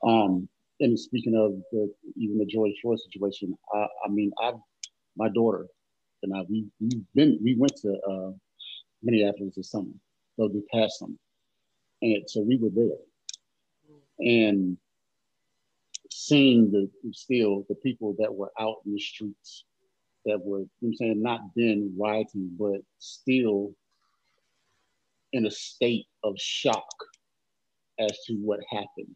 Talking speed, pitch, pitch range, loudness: 145 wpm, 105 Hz, 100-115 Hz, -27 LUFS